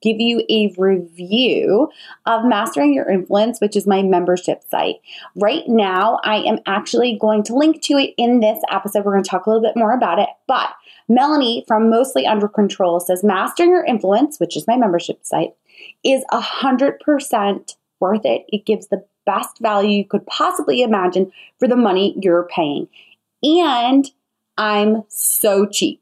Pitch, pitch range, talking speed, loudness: 215 Hz, 195-240 Hz, 170 wpm, -17 LUFS